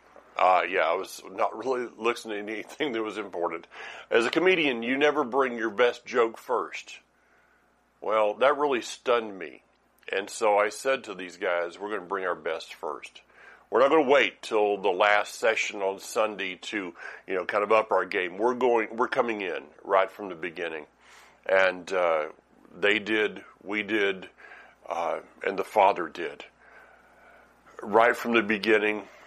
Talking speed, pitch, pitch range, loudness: 170 wpm, 110 Hz, 105-120 Hz, -26 LUFS